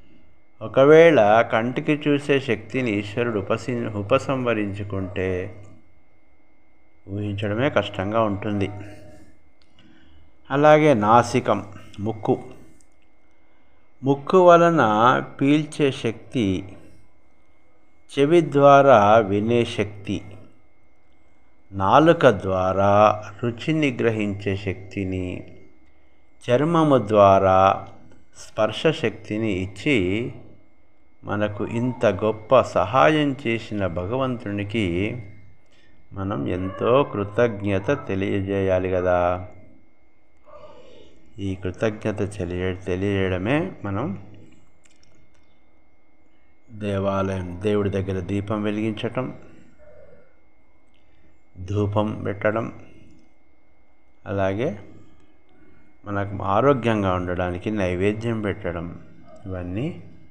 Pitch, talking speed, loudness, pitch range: 105 Hz, 60 wpm, -21 LUFS, 95-115 Hz